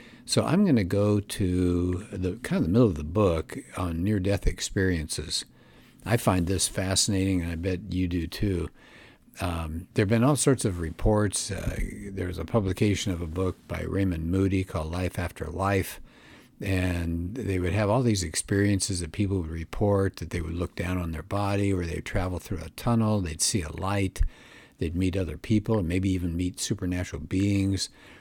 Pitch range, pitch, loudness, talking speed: 85-100 Hz, 95 Hz, -27 LUFS, 185 wpm